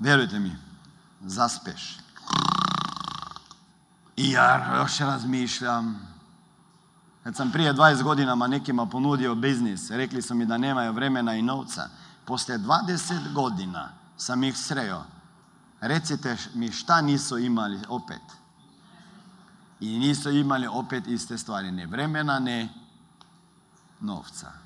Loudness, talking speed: -26 LUFS, 110 wpm